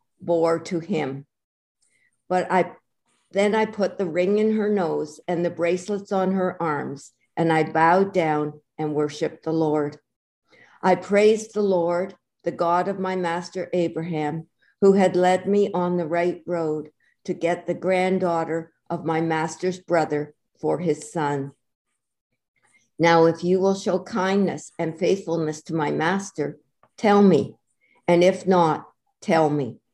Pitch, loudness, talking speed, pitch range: 170 Hz, -23 LUFS, 150 wpm, 155-185 Hz